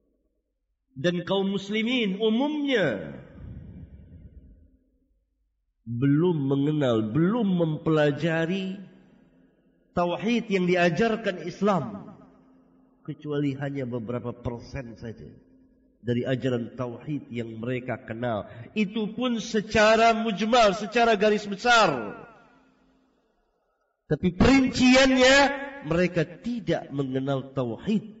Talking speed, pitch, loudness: 75 wpm, 170 Hz, -24 LUFS